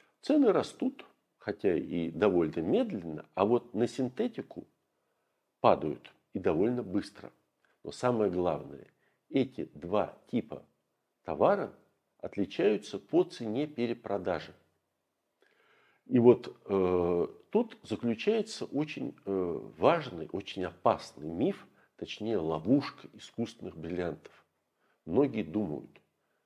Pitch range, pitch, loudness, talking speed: 85-125 Hz, 105 Hz, -31 LUFS, 95 wpm